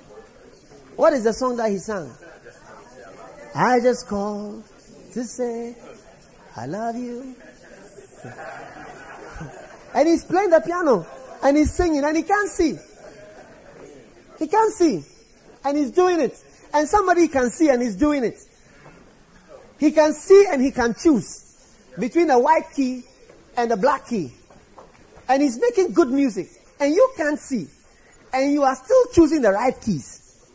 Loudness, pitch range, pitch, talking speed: -20 LUFS, 235-320 Hz, 270 Hz, 145 wpm